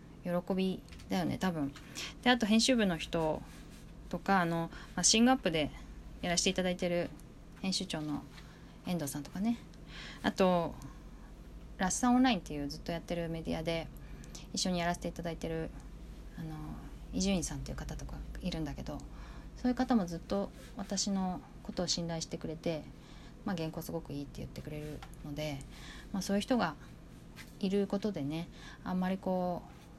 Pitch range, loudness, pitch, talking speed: 160-195 Hz, -34 LUFS, 175 Hz, 335 characters per minute